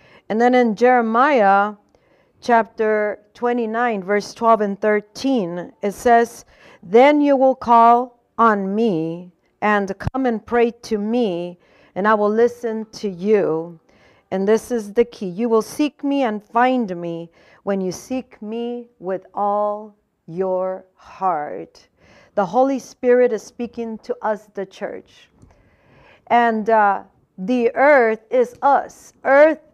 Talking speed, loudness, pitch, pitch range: 135 wpm, -18 LUFS, 225 Hz, 205-240 Hz